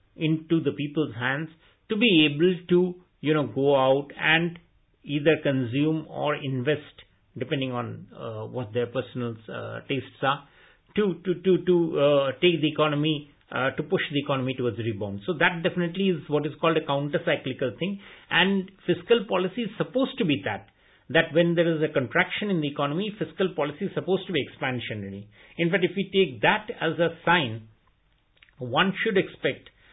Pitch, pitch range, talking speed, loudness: 155 Hz, 135-175 Hz, 175 wpm, -25 LUFS